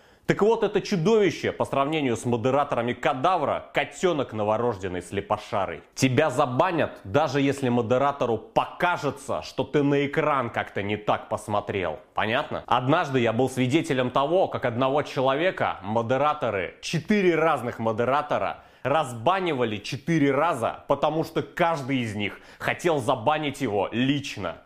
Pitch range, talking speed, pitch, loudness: 120-155 Hz, 125 wpm, 140 Hz, -25 LUFS